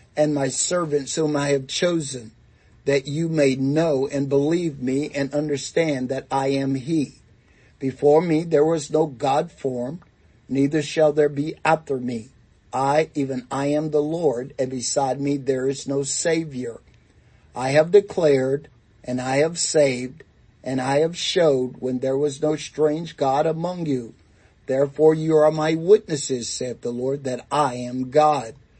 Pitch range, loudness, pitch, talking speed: 130-155 Hz, -22 LUFS, 140 Hz, 160 wpm